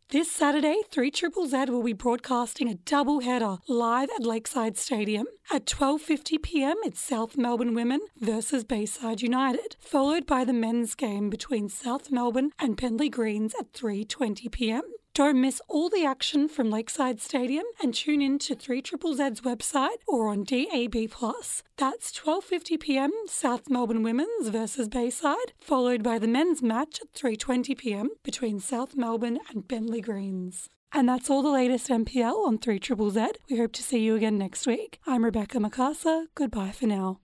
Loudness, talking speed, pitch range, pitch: -28 LUFS, 160 wpm, 230-285 Hz, 250 Hz